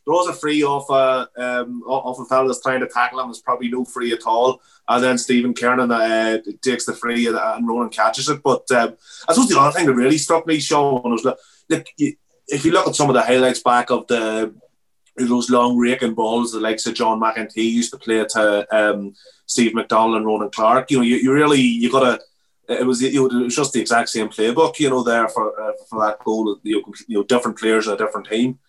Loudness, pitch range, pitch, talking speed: -18 LUFS, 110-130 Hz, 120 Hz, 230 wpm